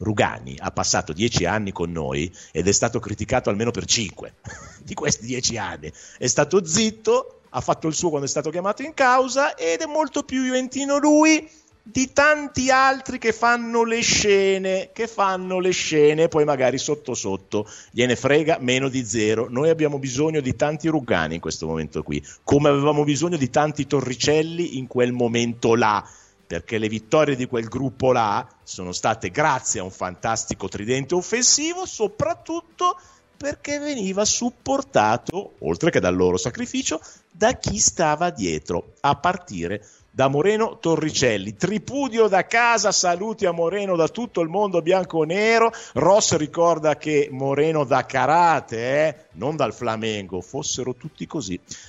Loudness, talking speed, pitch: -21 LUFS, 155 wpm, 150 Hz